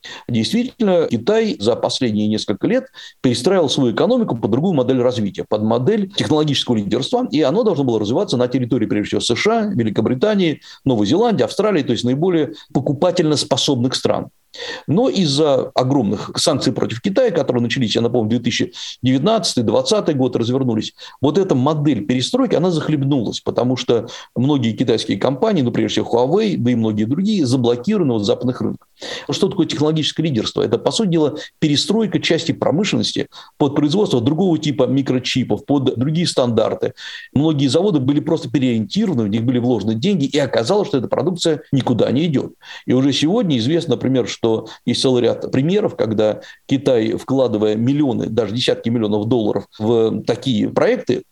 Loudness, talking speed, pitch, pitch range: -17 LUFS, 155 wpm, 135 Hz, 120-165 Hz